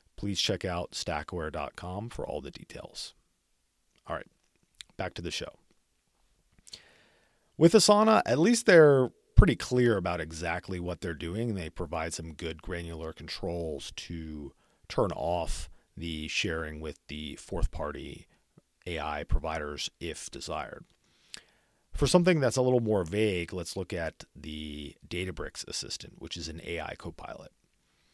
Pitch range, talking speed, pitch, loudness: 80-95 Hz, 135 wpm, 85 Hz, -30 LUFS